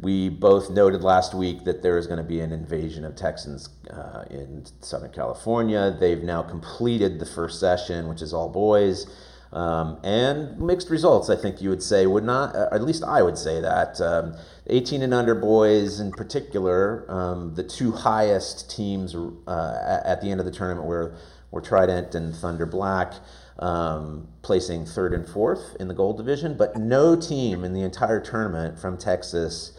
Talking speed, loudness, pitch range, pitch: 180 wpm, -24 LUFS, 85-105 Hz, 90 Hz